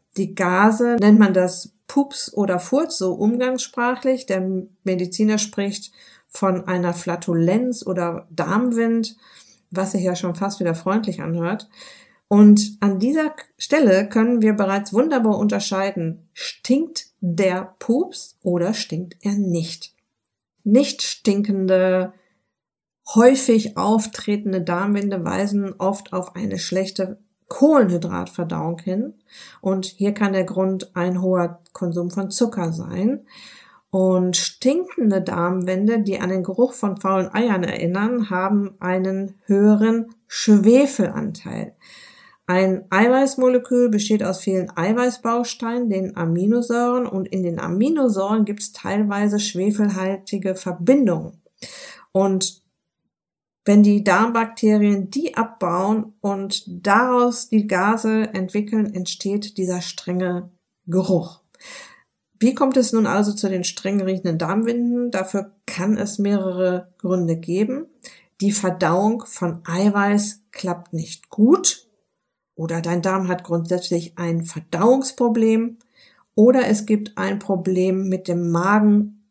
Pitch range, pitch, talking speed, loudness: 185-225 Hz, 200 Hz, 115 wpm, -20 LUFS